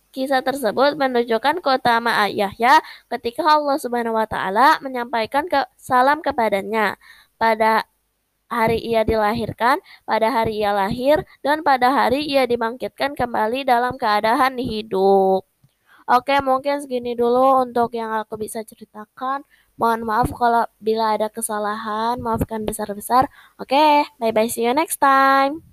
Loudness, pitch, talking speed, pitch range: -19 LUFS, 235 Hz, 135 wpm, 220-270 Hz